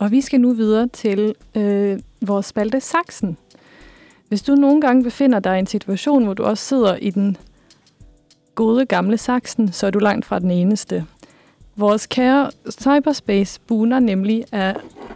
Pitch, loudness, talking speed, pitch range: 220 Hz, -18 LUFS, 160 wpm, 205-260 Hz